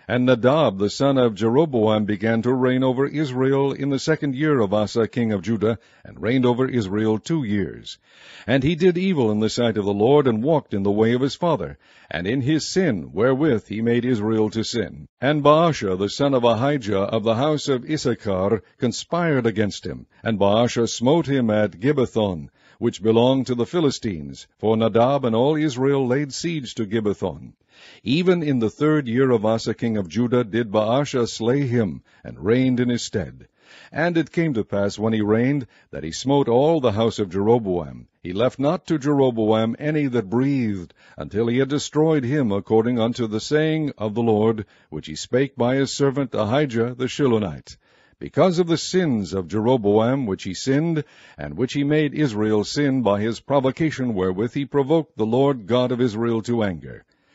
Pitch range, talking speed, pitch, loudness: 110-140 Hz, 190 wpm, 120 Hz, -21 LUFS